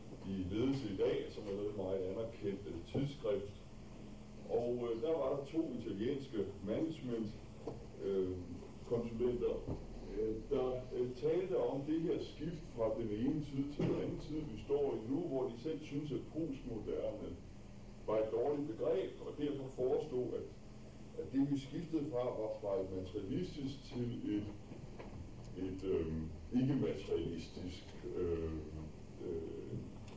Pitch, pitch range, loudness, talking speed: 115 Hz, 100-140 Hz, -40 LUFS, 140 wpm